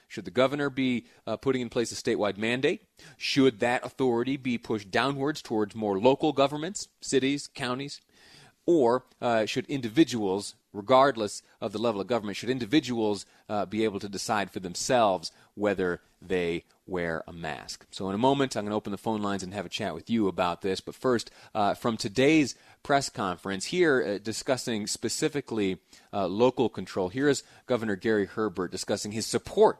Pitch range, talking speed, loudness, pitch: 100-130 Hz, 175 wpm, -28 LUFS, 115 Hz